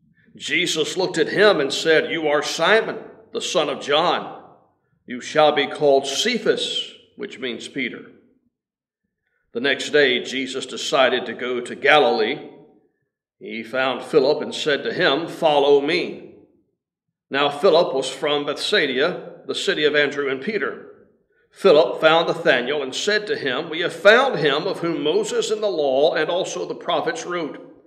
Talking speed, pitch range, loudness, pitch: 155 wpm, 145-220 Hz, -20 LUFS, 155 Hz